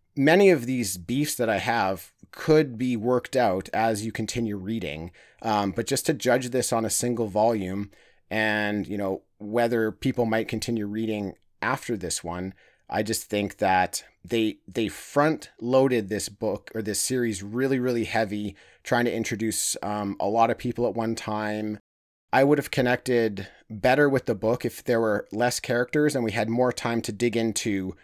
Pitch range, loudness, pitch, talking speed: 105-125 Hz, -25 LUFS, 115 Hz, 180 wpm